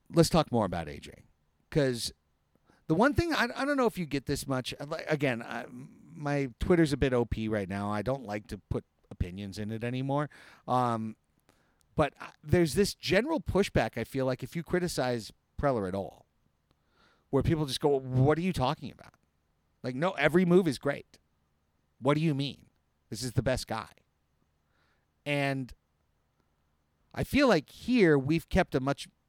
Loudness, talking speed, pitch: -30 LUFS, 170 wpm, 130 Hz